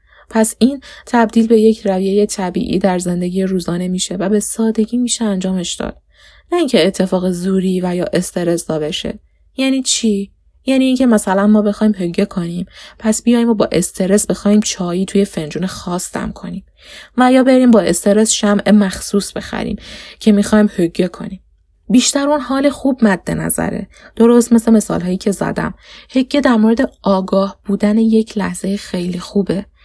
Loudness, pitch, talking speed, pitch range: -15 LUFS, 205 Hz, 155 wpm, 185-230 Hz